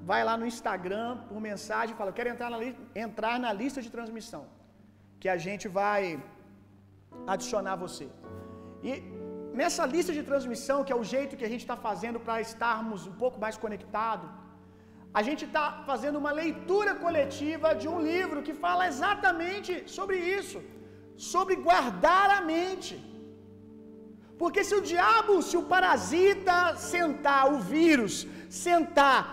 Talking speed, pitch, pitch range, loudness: 155 wpm, 265 Hz, 215-345 Hz, -29 LUFS